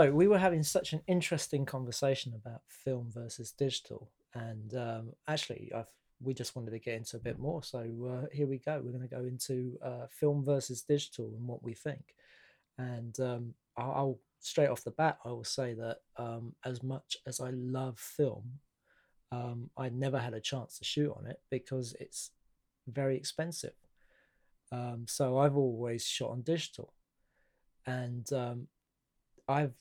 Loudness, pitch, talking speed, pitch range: -36 LUFS, 130 Hz, 170 wpm, 120-140 Hz